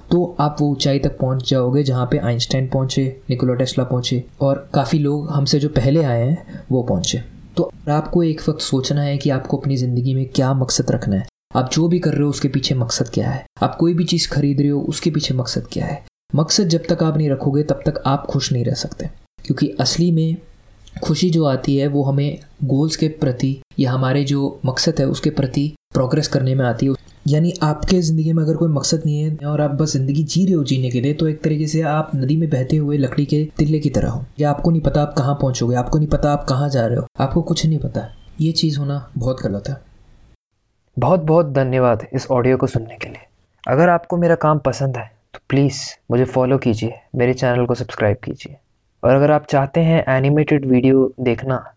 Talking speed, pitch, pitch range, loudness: 220 wpm, 140 Hz, 130-155 Hz, -18 LUFS